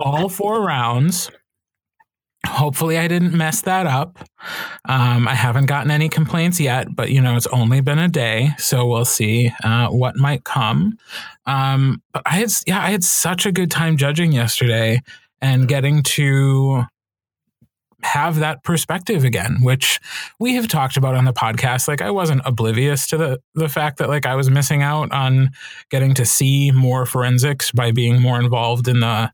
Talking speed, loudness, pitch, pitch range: 175 wpm, -17 LUFS, 135 Hz, 125-160 Hz